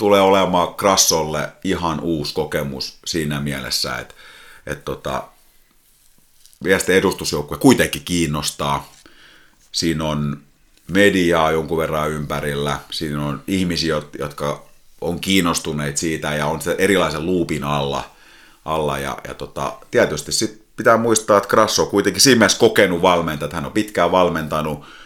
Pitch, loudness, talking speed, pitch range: 80 Hz, -18 LUFS, 125 wpm, 75-85 Hz